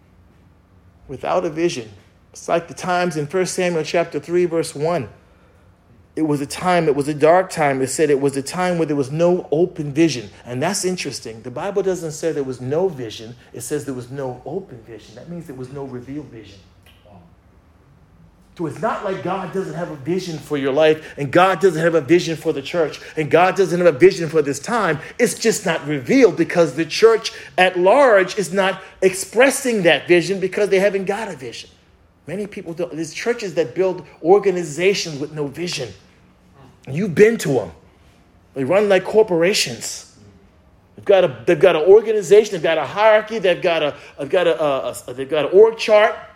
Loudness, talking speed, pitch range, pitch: -18 LUFS, 200 wpm, 125-185 Hz, 165 Hz